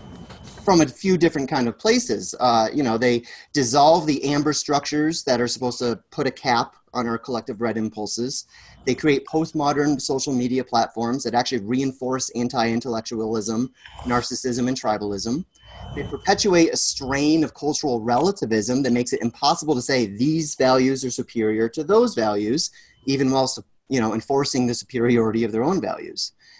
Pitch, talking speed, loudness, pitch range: 130 Hz, 160 wpm, -22 LUFS, 115-145 Hz